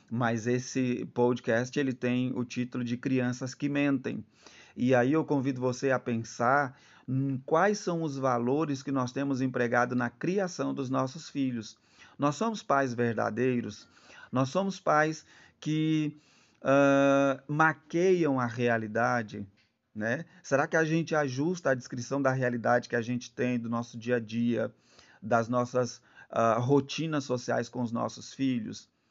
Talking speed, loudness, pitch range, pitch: 150 wpm, -29 LUFS, 120-145 Hz, 130 Hz